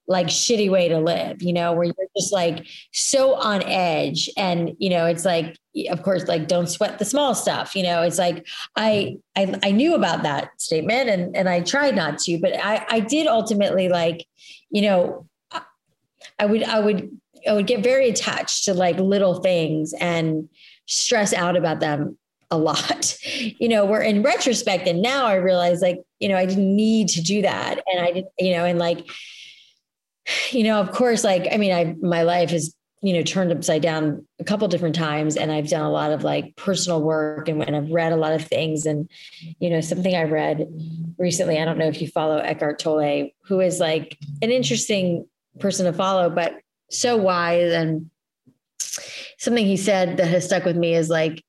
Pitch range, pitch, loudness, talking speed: 165-205 Hz, 180 Hz, -21 LUFS, 200 wpm